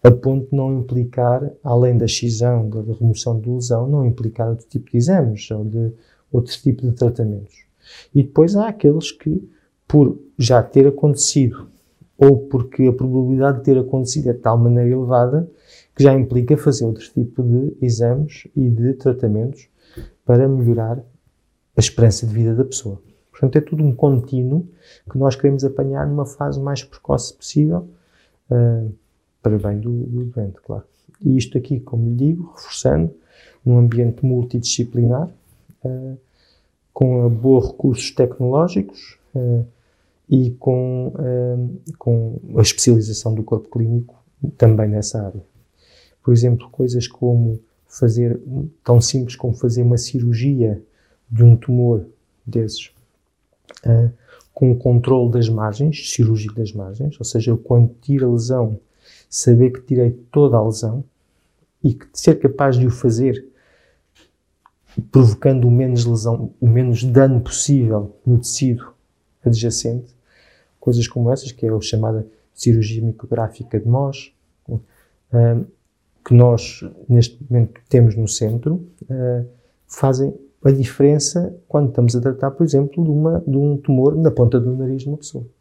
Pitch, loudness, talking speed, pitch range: 125 Hz, -17 LUFS, 140 wpm, 115-135 Hz